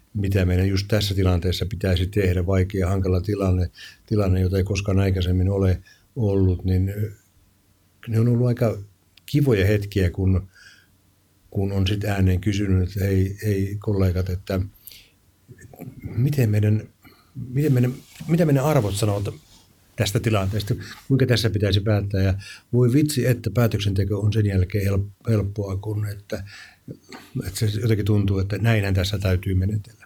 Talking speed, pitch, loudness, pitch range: 140 wpm, 100 Hz, -22 LUFS, 95-110 Hz